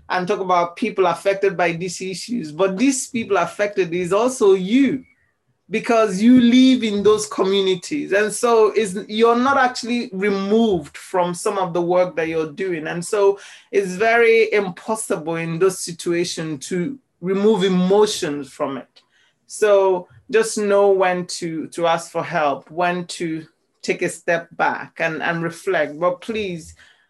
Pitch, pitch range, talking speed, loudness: 195 Hz, 175-215 Hz, 155 wpm, -19 LUFS